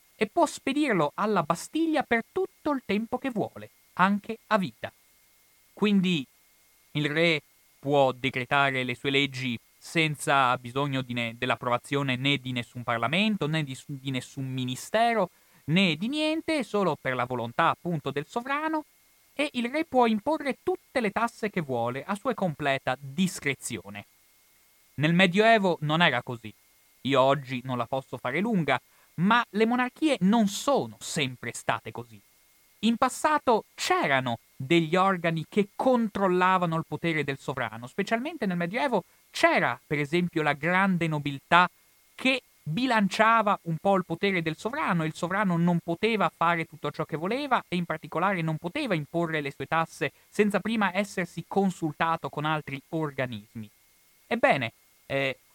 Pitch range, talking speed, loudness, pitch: 135-215 Hz, 145 wpm, -27 LUFS, 170 Hz